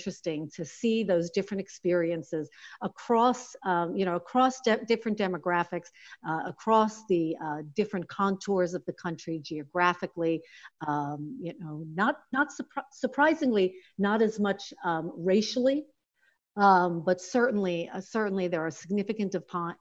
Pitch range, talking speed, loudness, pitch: 170-220 Hz, 135 wpm, -29 LUFS, 185 Hz